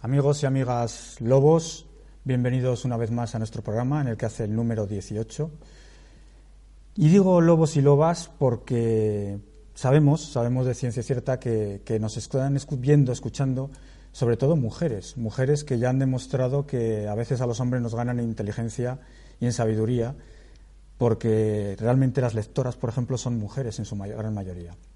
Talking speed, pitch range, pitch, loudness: 165 wpm, 115-135 Hz, 125 Hz, -25 LUFS